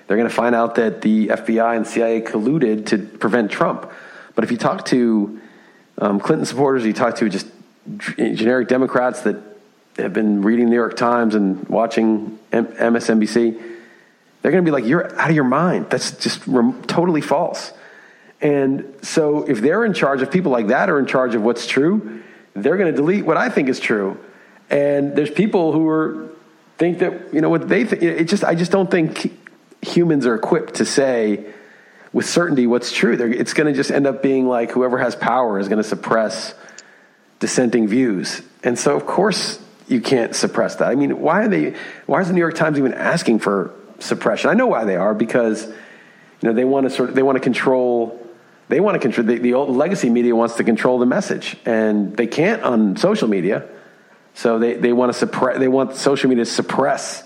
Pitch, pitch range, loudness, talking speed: 125 Hz, 115-145 Hz, -18 LUFS, 205 wpm